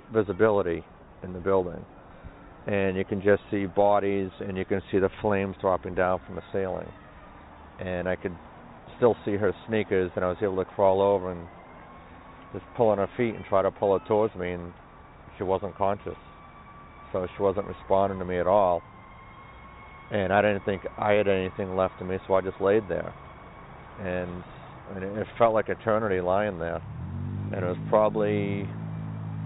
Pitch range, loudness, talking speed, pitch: 90-105 Hz, -27 LUFS, 175 wpm, 95 Hz